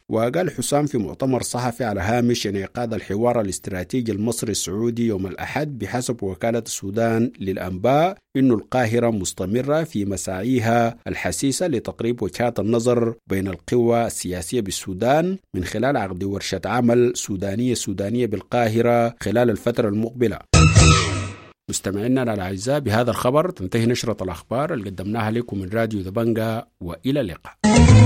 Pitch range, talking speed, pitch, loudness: 100-120 Hz, 120 wpm, 115 Hz, -21 LUFS